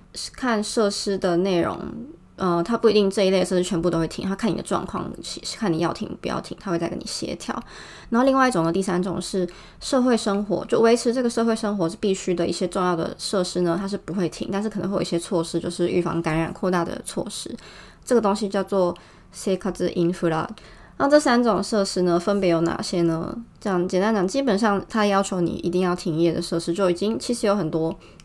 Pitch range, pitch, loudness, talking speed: 175-210 Hz, 185 Hz, -23 LUFS, 345 characters per minute